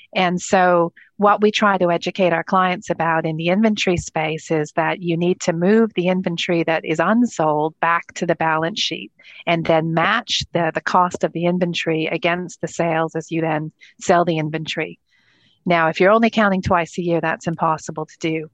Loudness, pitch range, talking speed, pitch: -19 LUFS, 160-185 Hz, 195 wpm, 170 Hz